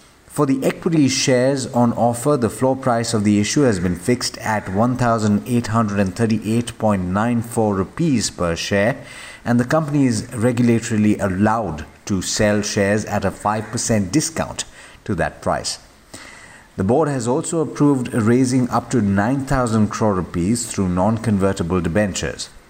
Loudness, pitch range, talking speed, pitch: -19 LUFS, 100-125 Hz, 130 wpm, 110 Hz